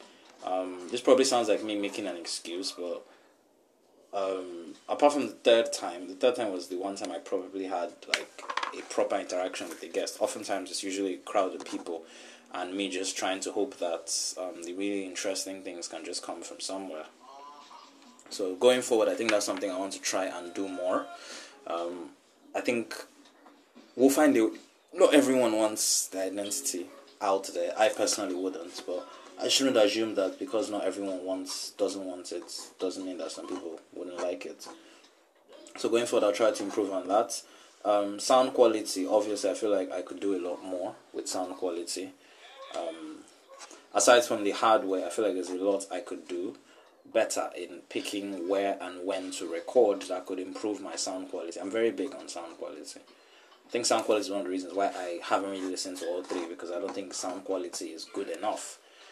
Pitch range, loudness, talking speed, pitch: 95-110 Hz, -30 LUFS, 195 wpm, 100 Hz